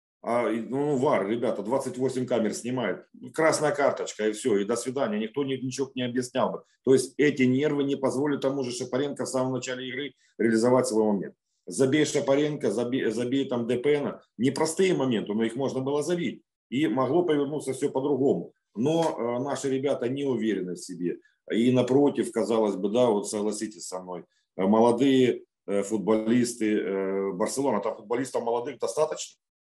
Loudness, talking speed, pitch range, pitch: -26 LUFS, 160 wpm, 115-140 Hz, 130 Hz